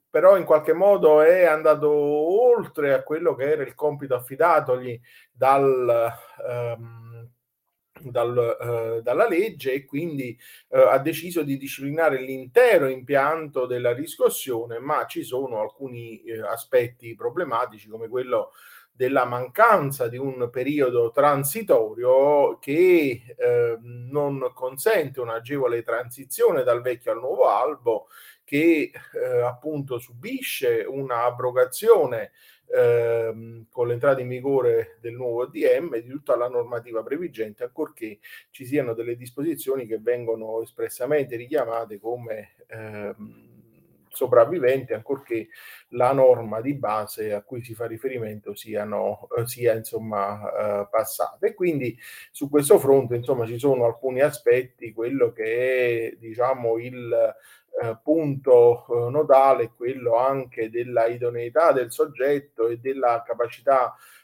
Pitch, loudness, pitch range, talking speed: 130 Hz, -23 LUFS, 120-165 Hz, 120 wpm